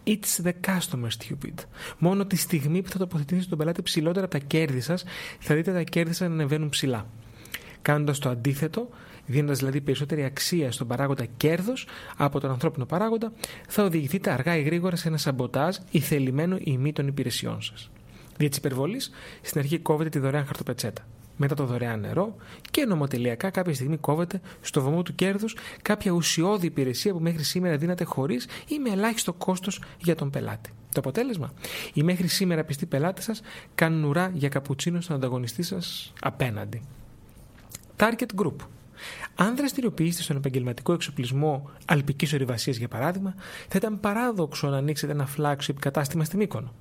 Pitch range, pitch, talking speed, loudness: 135-180 Hz, 155 Hz, 165 wpm, -27 LUFS